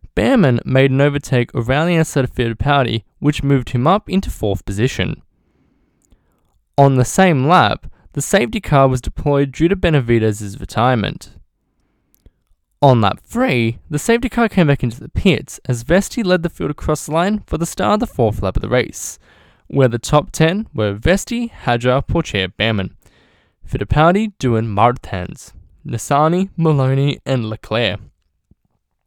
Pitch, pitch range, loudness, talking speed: 135 Hz, 115-170 Hz, -16 LUFS, 155 wpm